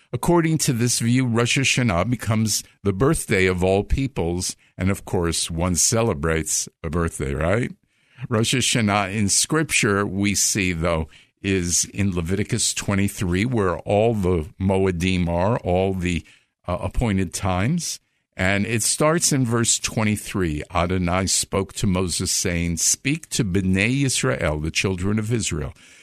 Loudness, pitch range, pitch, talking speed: -21 LUFS, 90-120 Hz, 100 Hz, 140 wpm